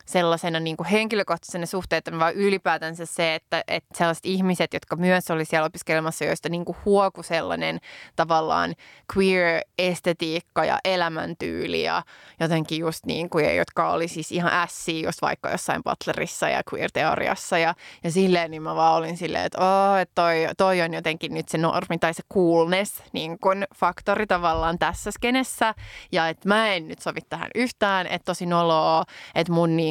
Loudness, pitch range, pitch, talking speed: -24 LUFS, 165-185 Hz, 170 Hz, 160 wpm